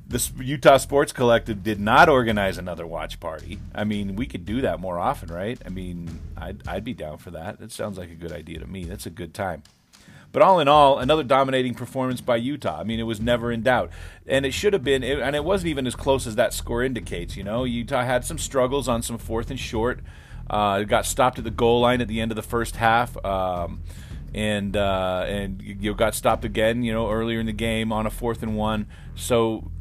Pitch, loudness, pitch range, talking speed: 110 Hz, -23 LUFS, 95-120 Hz, 240 wpm